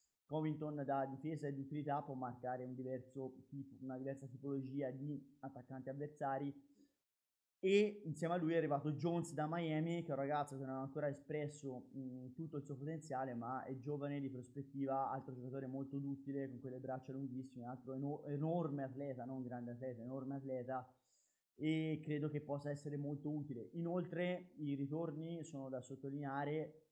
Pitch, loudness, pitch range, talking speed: 140 Hz, -44 LUFS, 130-150 Hz, 165 wpm